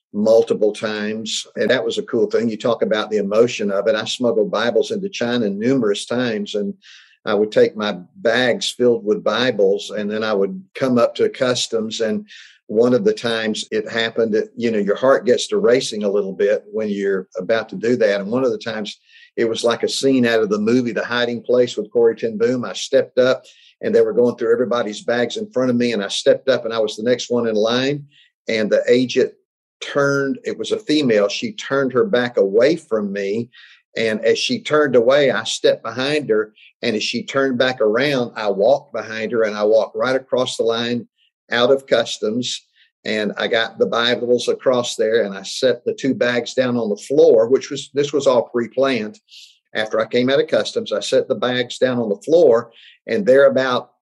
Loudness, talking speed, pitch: -18 LUFS, 215 wpm, 140 Hz